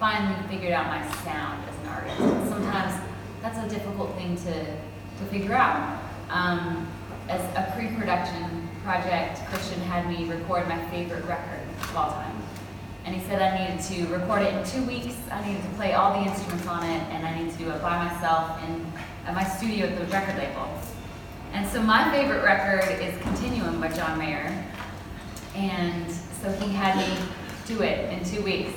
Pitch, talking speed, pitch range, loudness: 175 Hz, 185 wpm, 160-195 Hz, -28 LUFS